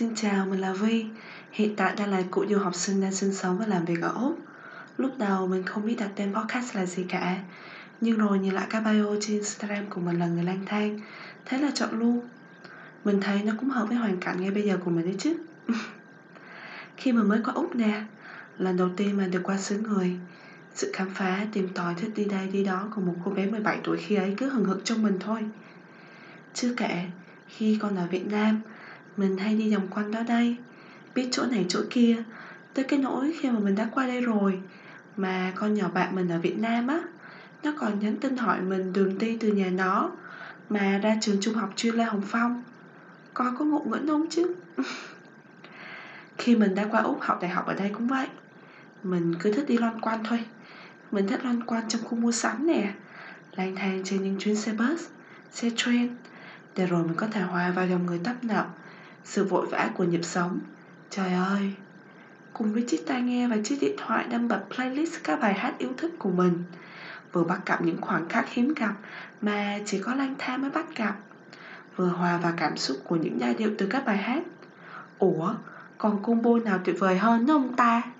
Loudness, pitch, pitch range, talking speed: -27 LUFS, 210 Hz, 190-235 Hz, 215 wpm